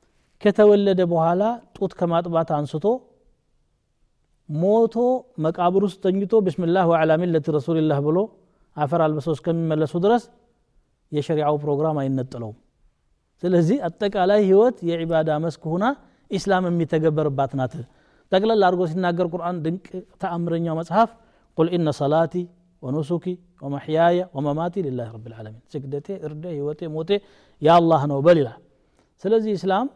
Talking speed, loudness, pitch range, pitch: 125 wpm, -22 LUFS, 155-190 Hz, 170 Hz